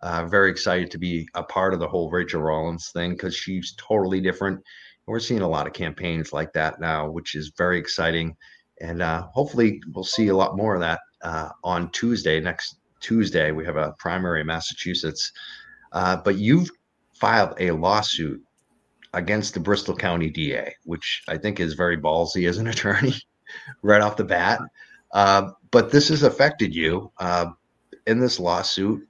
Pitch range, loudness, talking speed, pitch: 85-105 Hz, -23 LUFS, 175 wpm, 90 Hz